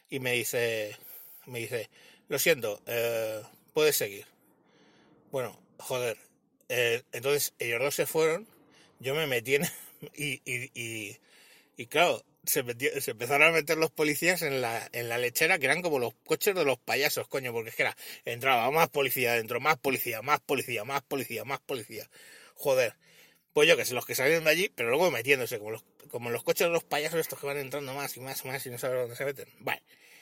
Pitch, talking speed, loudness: 160 Hz, 205 wpm, -29 LUFS